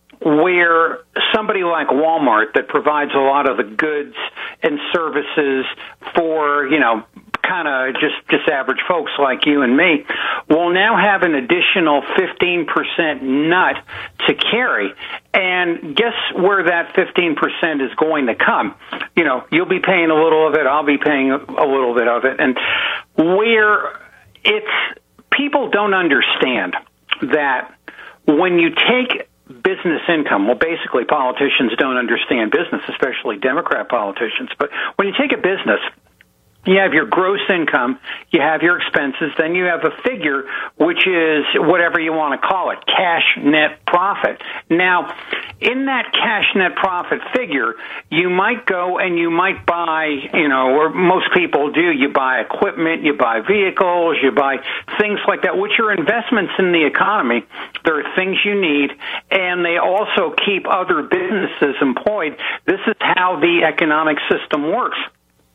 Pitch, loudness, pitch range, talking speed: 170 Hz, -16 LUFS, 150-190 Hz, 155 wpm